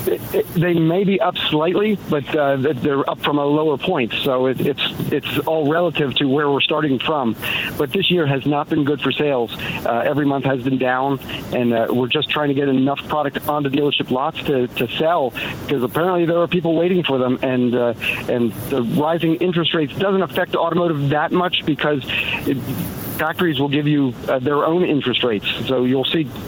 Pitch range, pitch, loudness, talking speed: 135-165 Hz, 145 Hz, -19 LUFS, 205 wpm